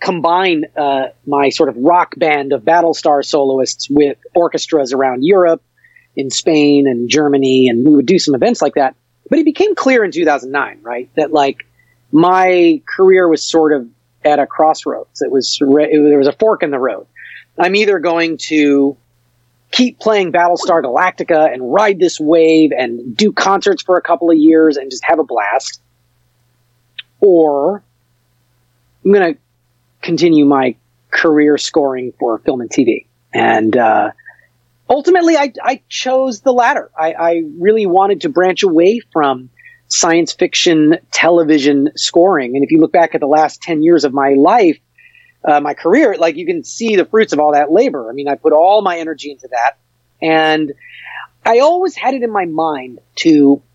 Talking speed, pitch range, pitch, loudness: 175 wpm, 135-180 Hz, 155 Hz, -12 LUFS